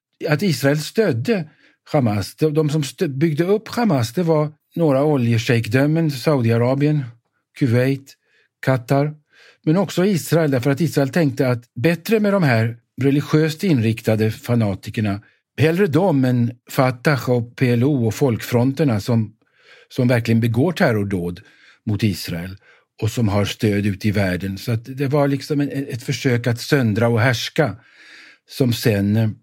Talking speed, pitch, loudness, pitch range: 135 wpm, 135 Hz, -19 LUFS, 115-150 Hz